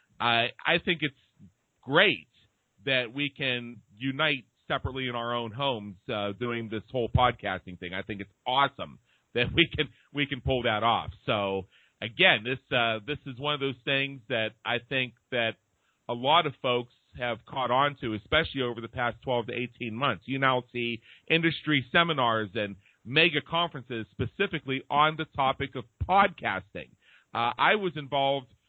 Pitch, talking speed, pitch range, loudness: 125 Hz, 165 wpm, 115-140 Hz, -28 LUFS